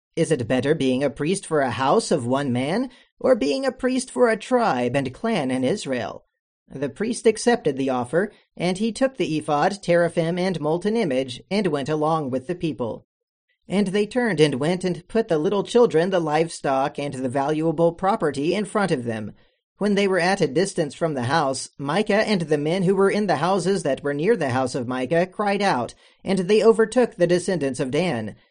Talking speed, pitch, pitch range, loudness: 205 wpm, 175 Hz, 145-205 Hz, -22 LUFS